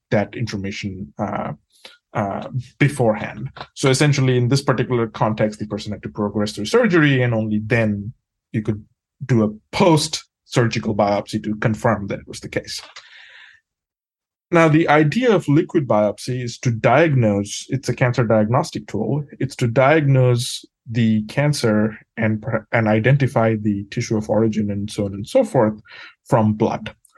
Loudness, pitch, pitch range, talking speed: -19 LUFS, 115 Hz, 105-135 Hz, 150 wpm